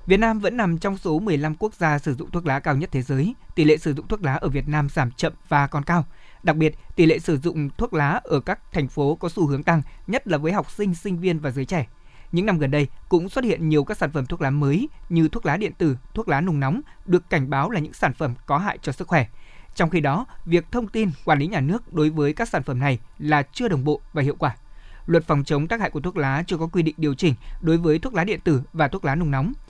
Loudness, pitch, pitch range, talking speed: -23 LUFS, 155 Hz, 145-175 Hz, 285 wpm